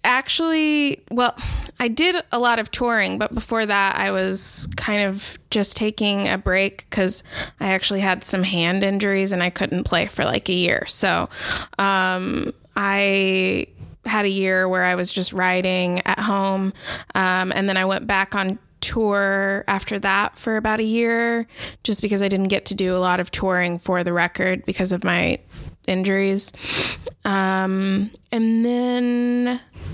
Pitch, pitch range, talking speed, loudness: 195 Hz, 185-220 Hz, 165 wpm, -20 LUFS